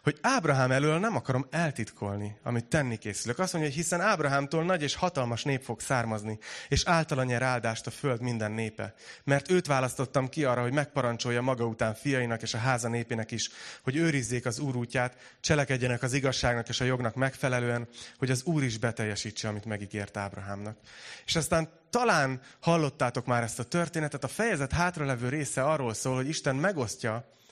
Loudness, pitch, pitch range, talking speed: -30 LUFS, 130 Hz, 115-150 Hz, 170 wpm